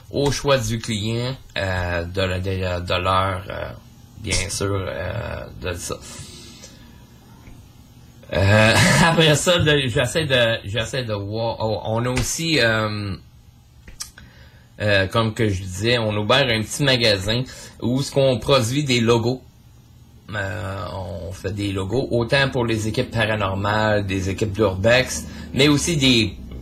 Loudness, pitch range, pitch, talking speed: -20 LUFS, 95-125 Hz, 110 Hz, 140 wpm